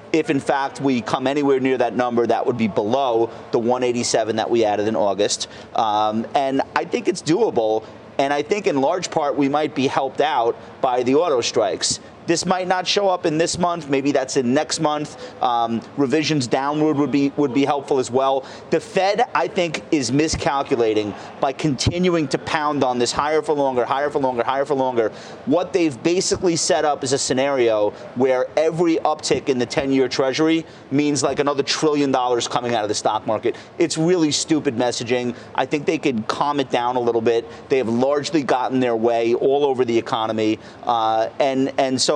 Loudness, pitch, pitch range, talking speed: -20 LUFS, 135 Hz, 120-155 Hz, 200 wpm